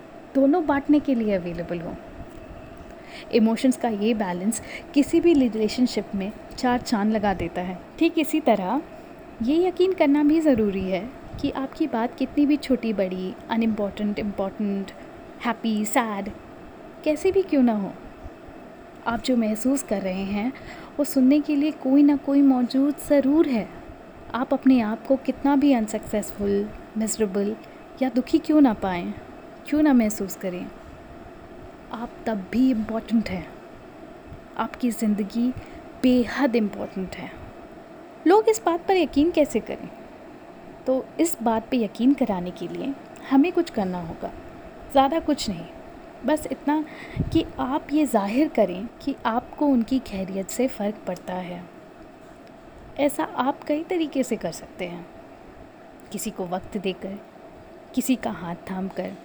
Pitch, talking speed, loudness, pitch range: 260 Hz, 145 wpm, -24 LUFS, 215-320 Hz